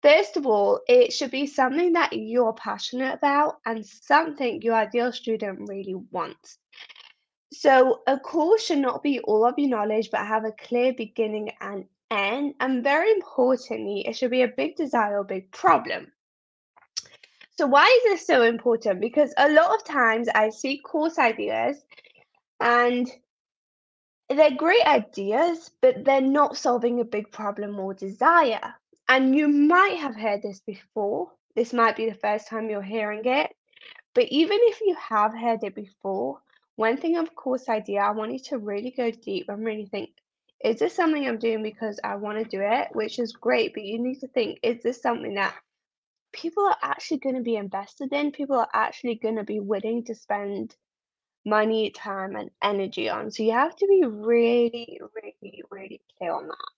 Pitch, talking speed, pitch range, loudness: 240 Hz, 180 wpm, 215-290 Hz, -24 LUFS